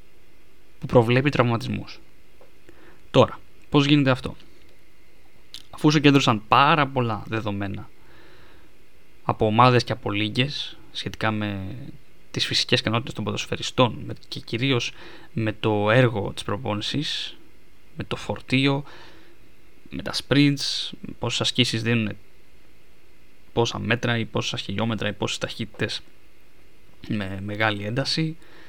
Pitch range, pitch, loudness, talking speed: 105-135 Hz, 115 Hz, -23 LUFS, 105 wpm